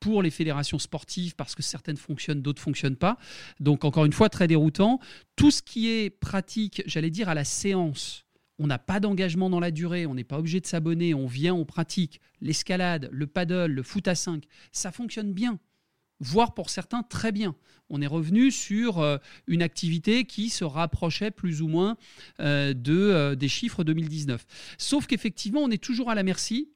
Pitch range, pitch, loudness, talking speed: 155-205 Hz, 175 Hz, -27 LUFS, 185 wpm